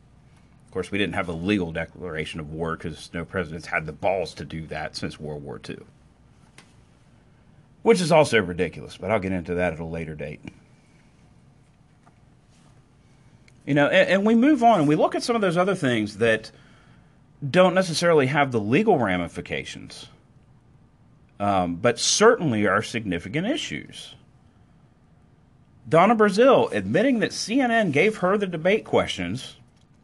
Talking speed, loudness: 150 wpm, -22 LUFS